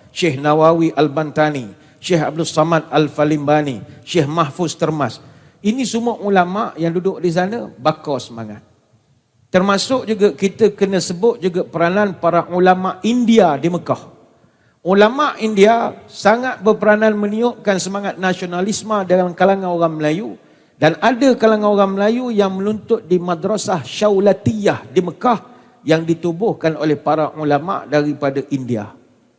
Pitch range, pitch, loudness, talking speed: 150-205 Hz, 180 Hz, -16 LUFS, 125 wpm